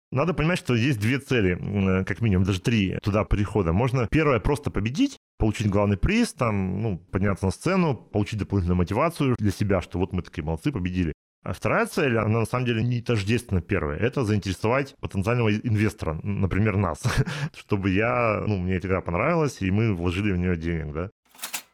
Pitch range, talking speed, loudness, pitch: 95-120 Hz, 180 wpm, -25 LUFS, 105 Hz